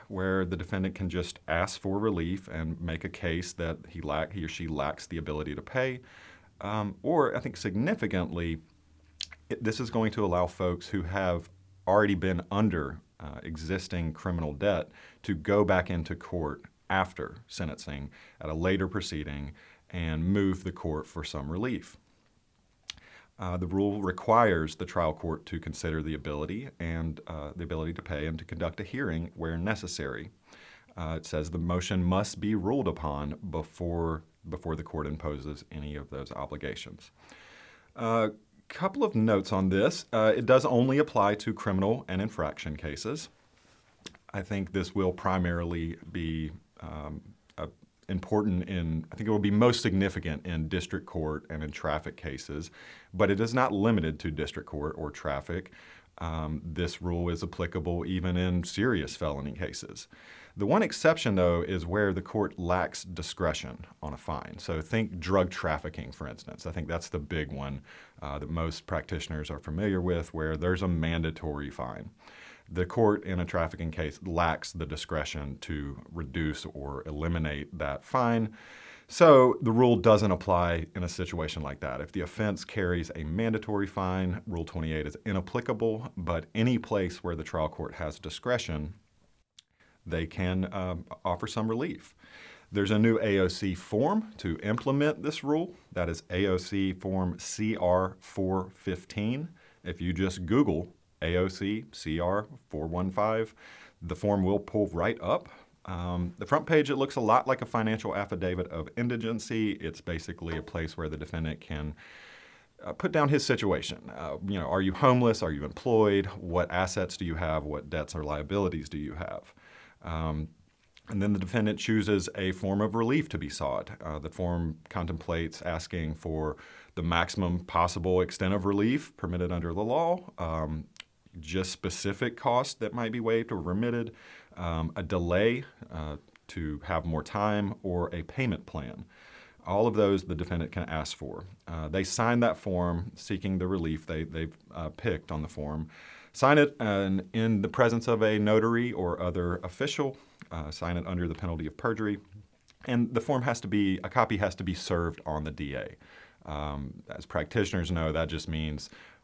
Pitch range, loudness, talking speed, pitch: 80-105 Hz, -31 LUFS, 165 wpm, 90 Hz